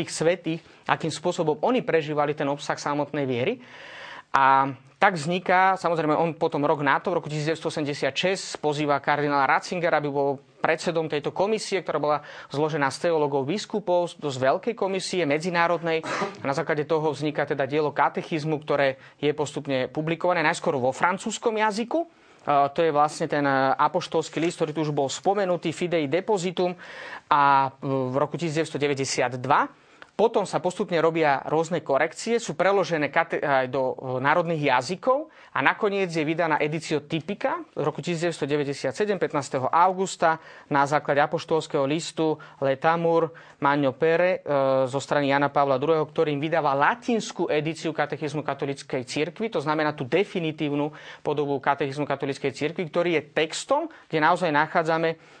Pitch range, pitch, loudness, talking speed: 145-175 Hz, 155 Hz, -25 LUFS, 140 wpm